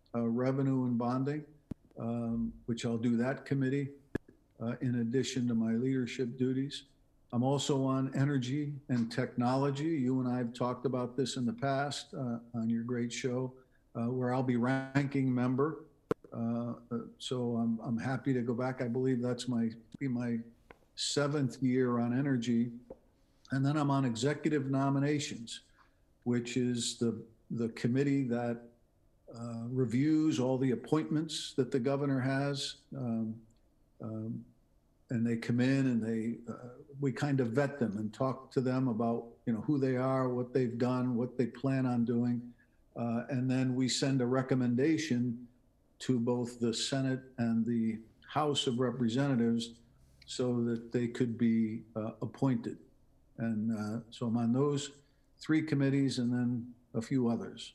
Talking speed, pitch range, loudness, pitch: 155 wpm, 115-135 Hz, -33 LUFS, 125 Hz